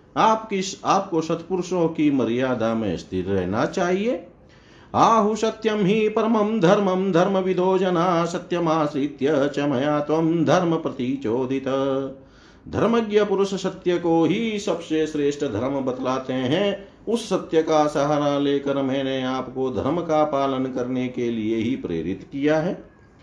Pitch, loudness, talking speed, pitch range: 155 Hz, -22 LUFS, 125 wpm, 135-185 Hz